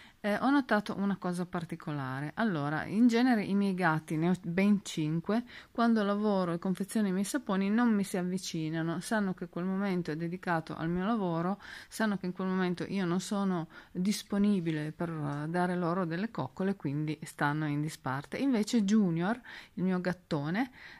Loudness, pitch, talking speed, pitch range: -32 LUFS, 185 Hz, 170 wpm, 165-205 Hz